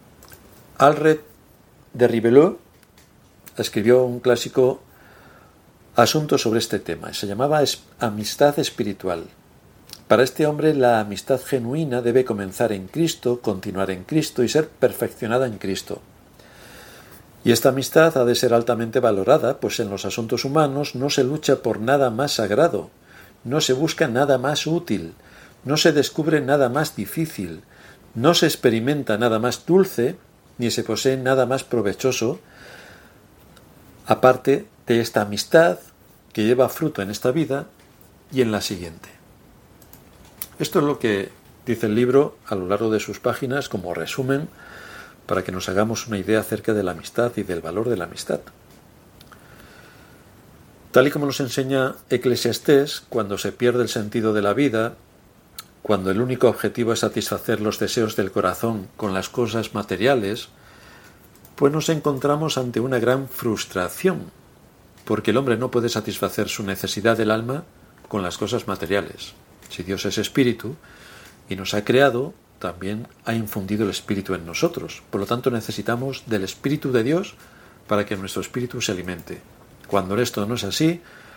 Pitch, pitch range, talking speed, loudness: 120 Hz, 105-135 Hz, 150 wpm, -21 LUFS